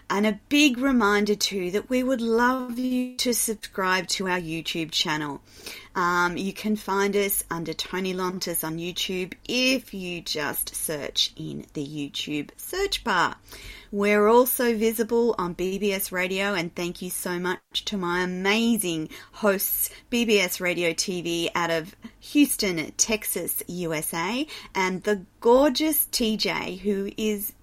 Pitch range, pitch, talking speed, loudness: 175-230 Hz, 195 Hz, 140 wpm, -25 LUFS